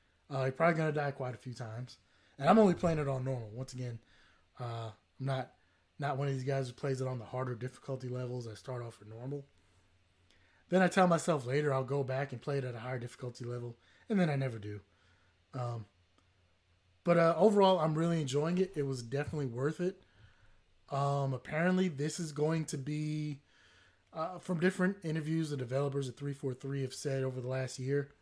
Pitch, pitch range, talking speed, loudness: 130 Hz, 115-150 Hz, 200 wpm, -34 LUFS